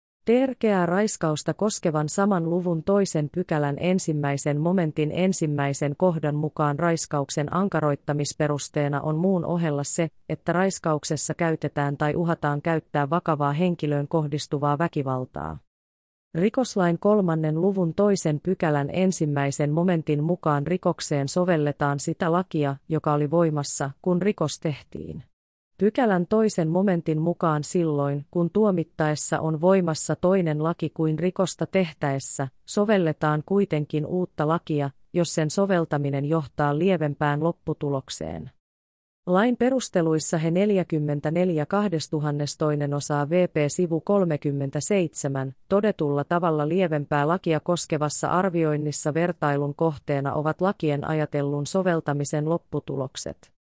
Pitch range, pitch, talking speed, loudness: 145-180 Hz, 160 Hz, 100 wpm, -24 LUFS